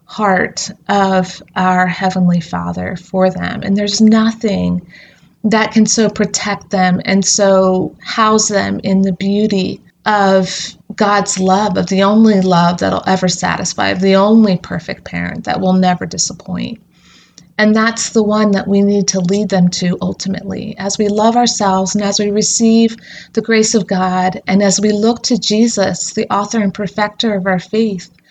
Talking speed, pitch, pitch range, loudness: 165 wpm, 195 Hz, 185-215 Hz, -13 LUFS